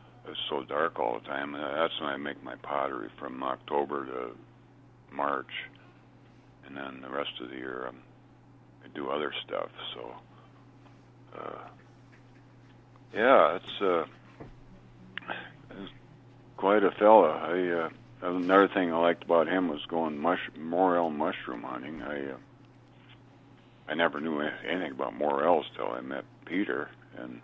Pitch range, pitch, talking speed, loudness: 70-95 Hz, 80 Hz, 140 wpm, -29 LUFS